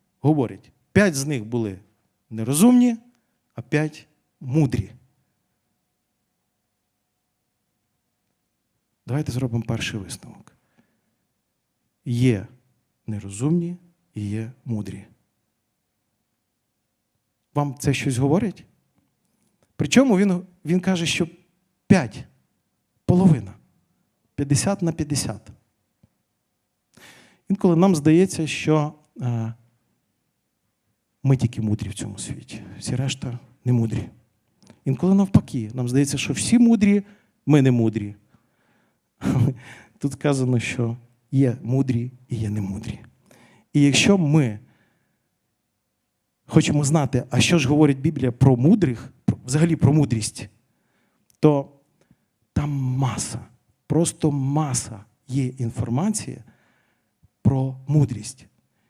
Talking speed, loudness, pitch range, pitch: 90 wpm, -22 LUFS, 115-155 Hz, 130 Hz